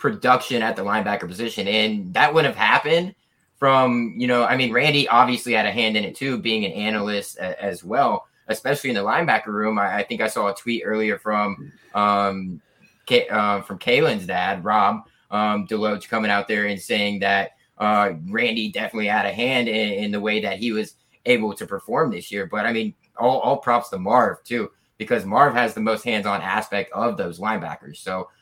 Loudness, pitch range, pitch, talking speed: -21 LUFS, 105-125 Hz, 110 Hz, 205 wpm